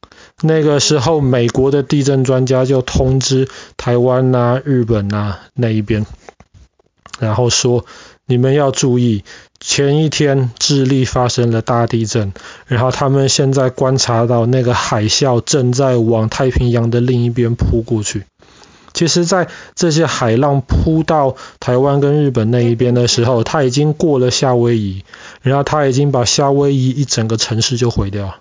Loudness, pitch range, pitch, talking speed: -14 LUFS, 120-140 Hz, 125 Hz, 240 characters per minute